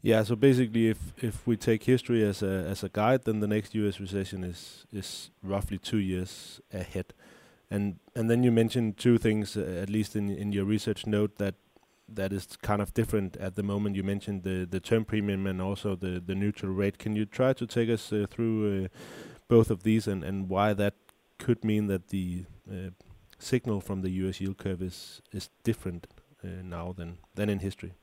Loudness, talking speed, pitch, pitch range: -30 LUFS, 205 wpm, 100 Hz, 95-110 Hz